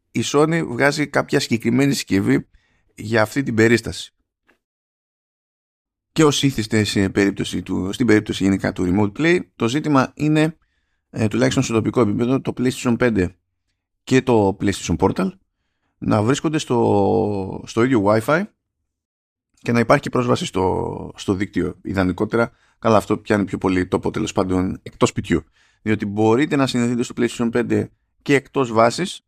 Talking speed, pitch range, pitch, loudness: 150 wpm, 95-130 Hz, 110 Hz, -19 LUFS